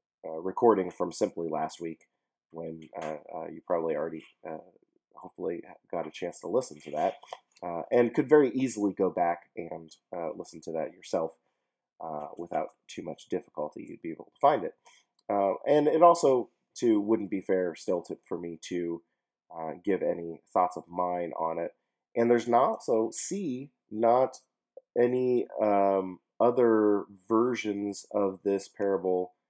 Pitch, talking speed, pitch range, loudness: 100 Hz, 160 wpm, 85-120 Hz, -29 LUFS